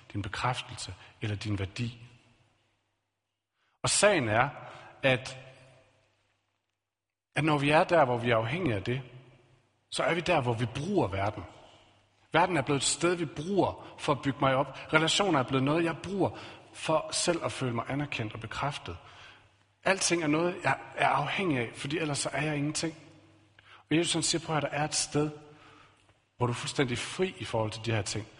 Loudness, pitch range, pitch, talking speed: -29 LUFS, 110-150 Hz, 125 Hz, 190 wpm